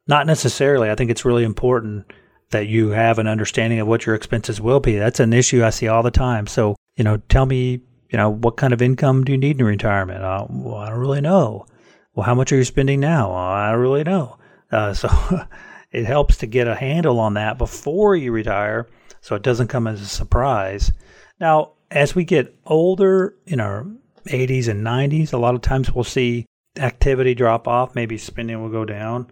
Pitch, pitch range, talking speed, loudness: 120 Hz, 110-135 Hz, 210 wpm, -19 LUFS